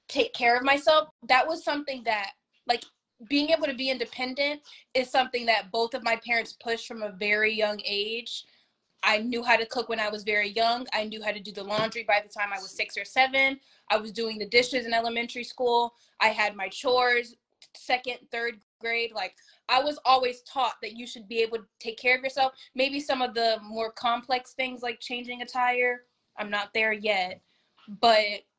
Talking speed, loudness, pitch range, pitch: 205 wpm, -27 LUFS, 215-255 Hz, 235 Hz